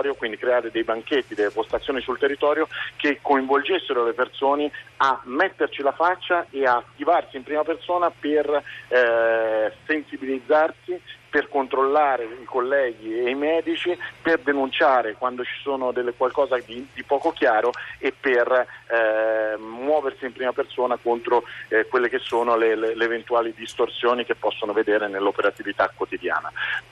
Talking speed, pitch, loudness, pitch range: 145 wpm, 135 Hz, -23 LUFS, 115-150 Hz